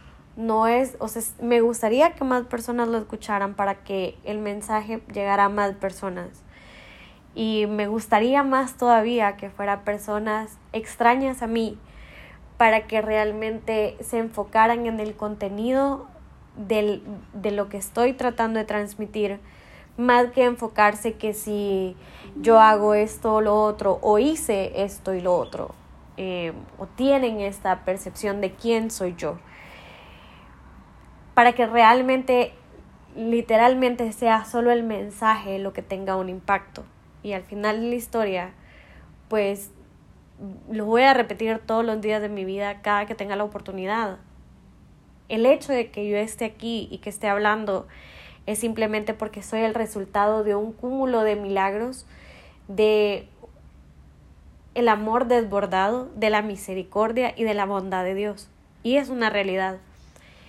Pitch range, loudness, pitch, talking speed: 200-230 Hz, -23 LUFS, 215 Hz, 145 wpm